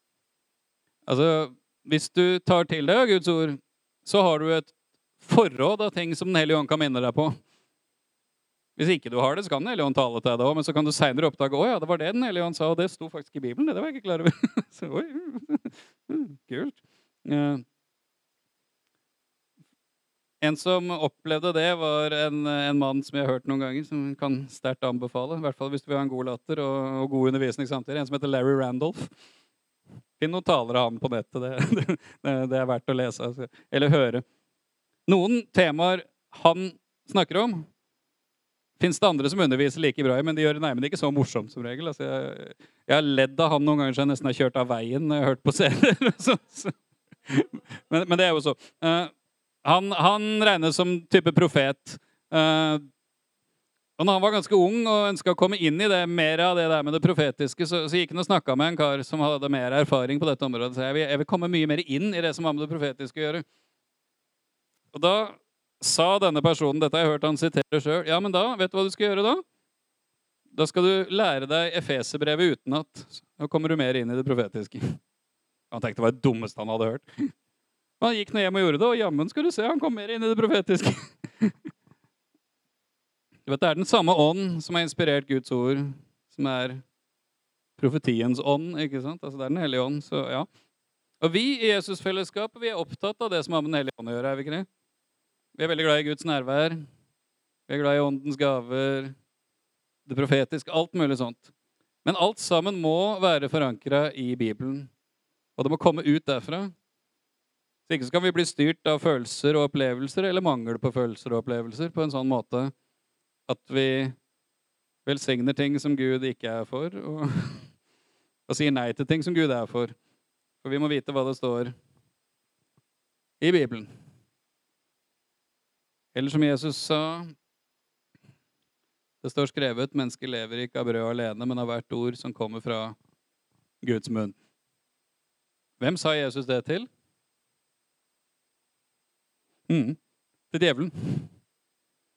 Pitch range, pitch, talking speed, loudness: 135-170 Hz, 150 Hz, 190 wpm, -25 LUFS